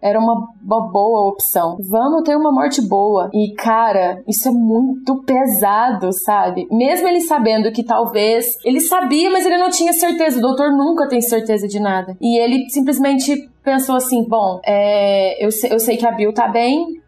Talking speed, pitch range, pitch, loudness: 180 wpm, 210-275 Hz, 235 Hz, -15 LUFS